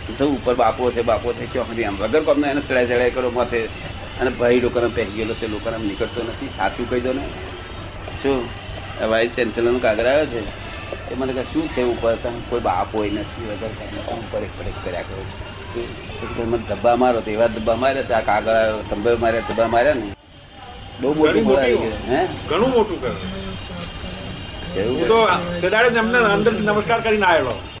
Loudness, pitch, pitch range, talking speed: -20 LUFS, 115 Hz, 100-125 Hz, 45 wpm